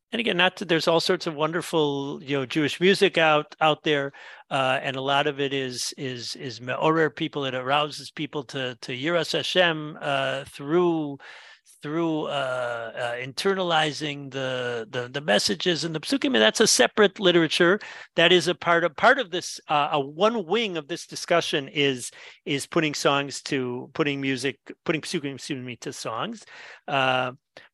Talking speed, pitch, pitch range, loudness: 170 wpm, 150 Hz, 135-170 Hz, -24 LUFS